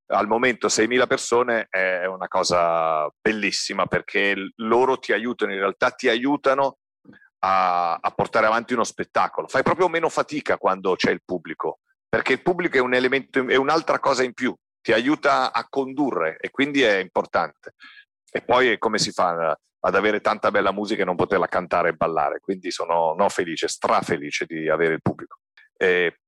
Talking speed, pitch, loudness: 175 wpm, 130 Hz, -22 LUFS